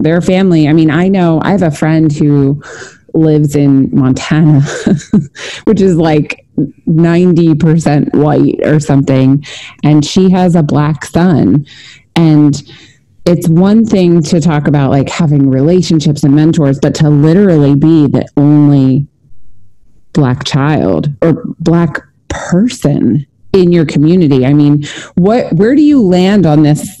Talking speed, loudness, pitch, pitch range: 140 wpm, -9 LUFS, 155 Hz, 140-170 Hz